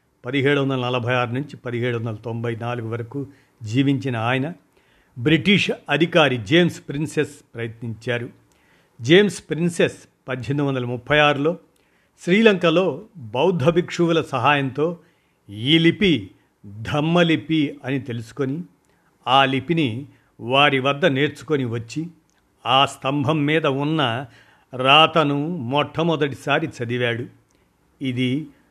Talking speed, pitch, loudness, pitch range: 95 wpm, 140 Hz, -20 LUFS, 125-160 Hz